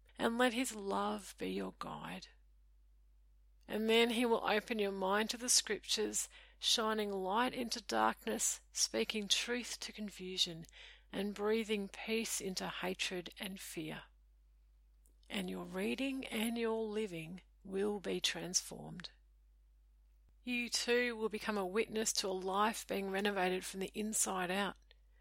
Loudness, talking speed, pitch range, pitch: -37 LUFS, 135 wpm, 175-225 Hz, 200 Hz